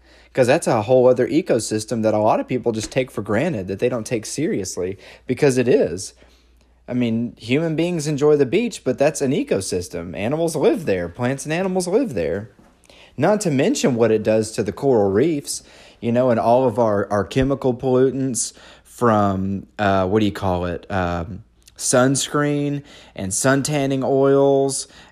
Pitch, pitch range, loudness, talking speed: 125 Hz, 105-140 Hz, -20 LUFS, 175 wpm